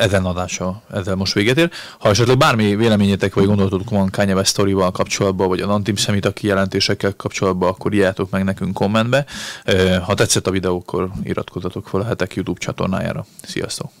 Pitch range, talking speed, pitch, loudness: 95-105 Hz, 165 wpm, 100 Hz, -18 LUFS